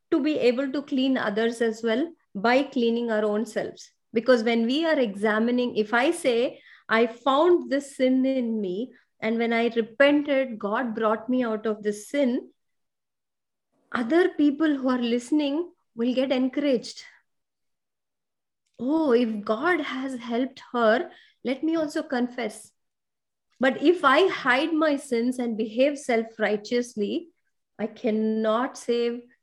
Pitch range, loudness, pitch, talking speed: 230-285 Hz, -25 LUFS, 245 Hz, 140 wpm